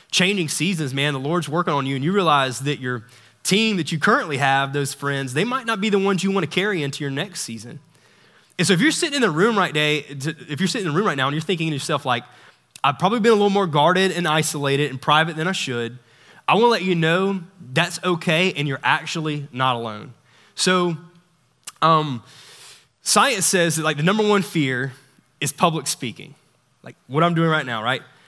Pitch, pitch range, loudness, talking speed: 155 Hz, 140-185 Hz, -20 LUFS, 225 wpm